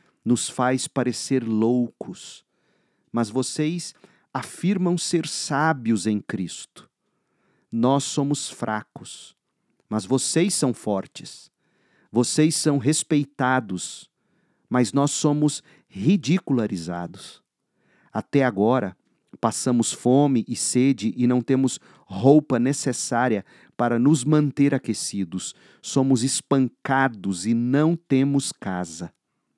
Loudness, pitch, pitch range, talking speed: -23 LUFS, 130 Hz, 115-145 Hz, 95 wpm